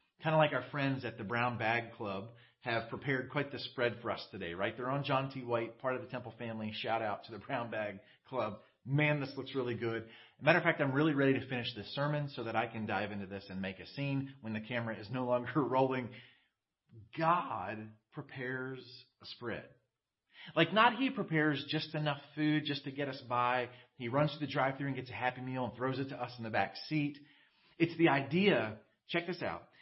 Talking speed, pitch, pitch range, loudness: 225 wpm, 130 Hz, 115-145 Hz, -35 LUFS